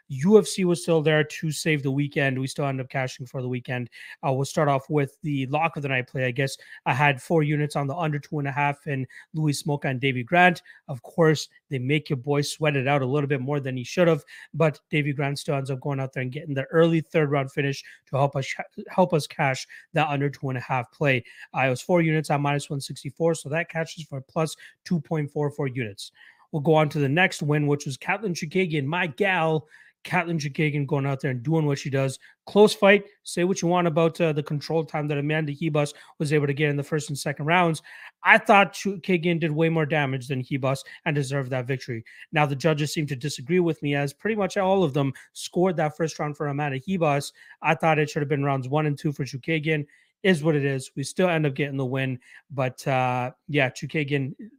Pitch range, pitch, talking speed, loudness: 140-160 Hz, 150 Hz, 235 wpm, -25 LUFS